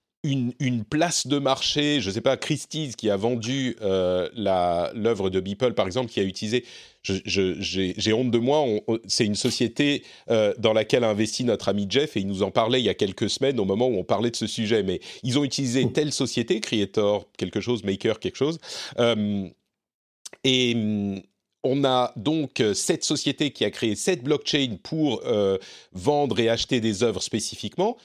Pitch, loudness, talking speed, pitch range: 120 Hz, -24 LUFS, 200 wpm, 105-140 Hz